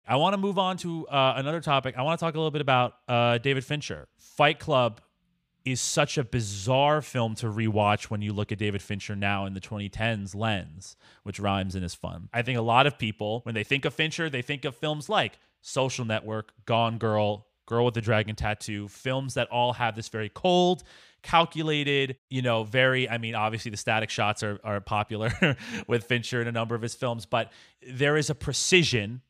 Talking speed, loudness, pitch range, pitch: 210 wpm, -27 LUFS, 110-140 Hz, 120 Hz